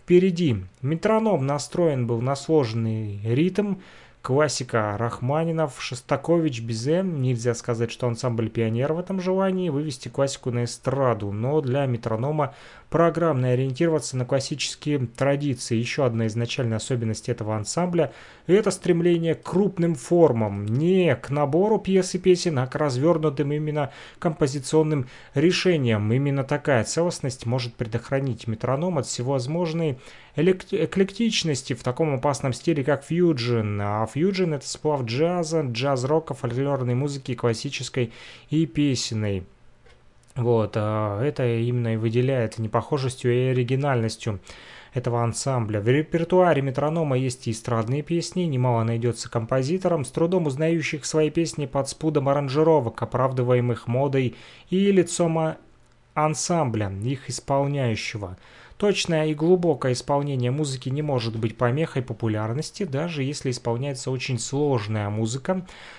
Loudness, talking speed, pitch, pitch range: -24 LUFS, 120 wpm, 140 Hz, 120-160 Hz